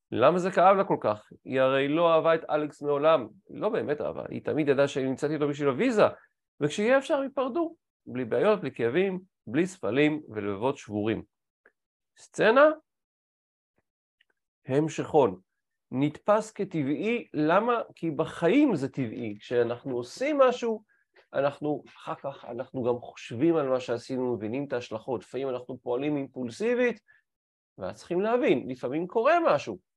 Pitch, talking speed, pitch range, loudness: 150 Hz, 140 wpm, 130-205 Hz, -27 LUFS